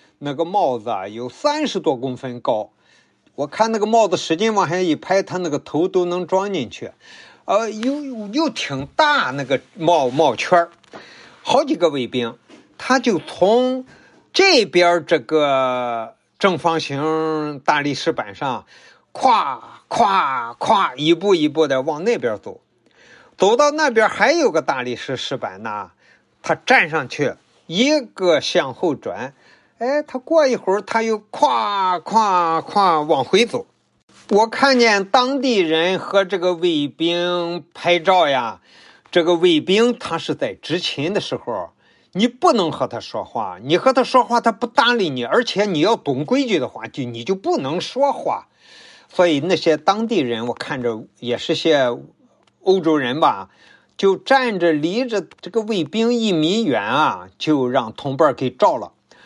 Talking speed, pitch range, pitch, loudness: 210 characters per minute, 155-230 Hz, 180 Hz, -18 LUFS